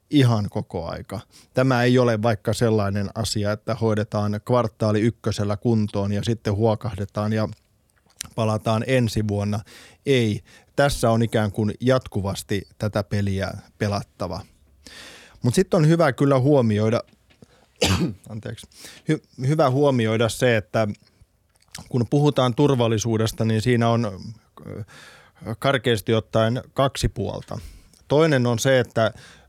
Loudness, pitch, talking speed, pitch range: -22 LUFS, 110 Hz, 115 wpm, 105-125 Hz